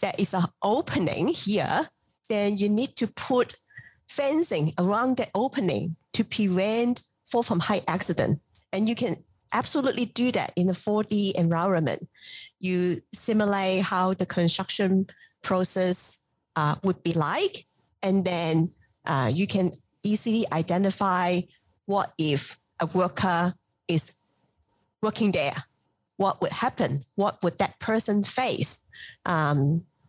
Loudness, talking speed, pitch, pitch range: -25 LUFS, 125 wpm, 190 Hz, 170-210 Hz